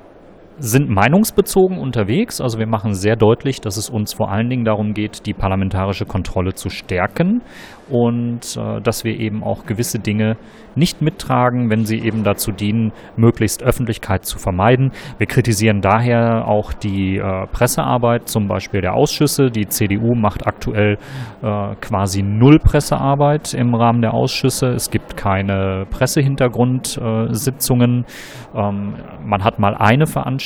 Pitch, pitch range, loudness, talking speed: 110 Hz, 105-125 Hz, -17 LUFS, 145 wpm